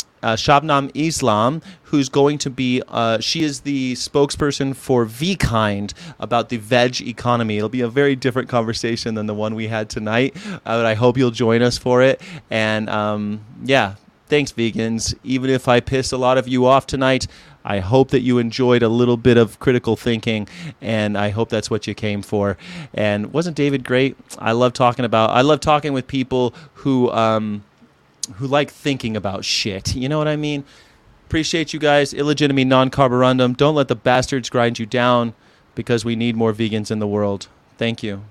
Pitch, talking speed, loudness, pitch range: 125 Hz, 190 wpm, -18 LUFS, 110-135 Hz